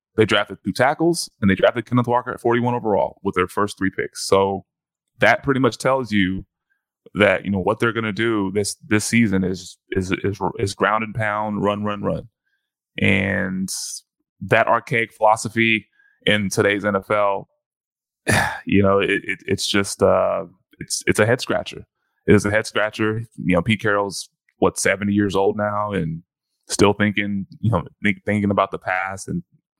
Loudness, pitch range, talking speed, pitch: -20 LUFS, 95-115 Hz, 175 wpm, 105 Hz